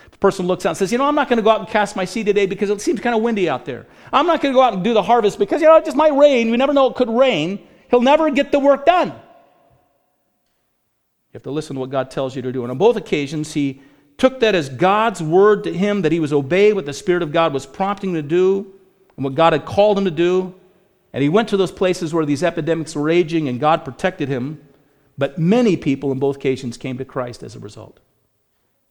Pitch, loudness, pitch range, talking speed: 185 Hz, -17 LUFS, 145-220 Hz, 265 wpm